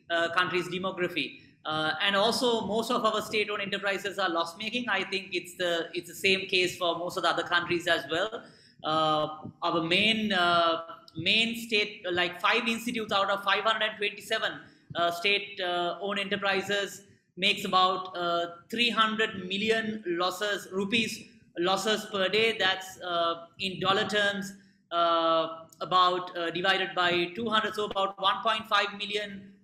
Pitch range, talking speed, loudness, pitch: 175-205 Hz, 140 wpm, -28 LUFS, 190 Hz